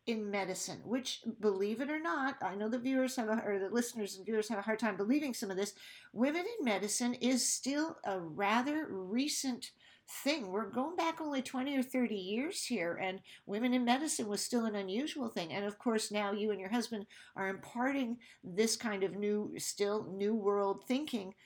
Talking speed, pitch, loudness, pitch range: 200 wpm, 225 Hz, -36 LUFS, 205-255 Hz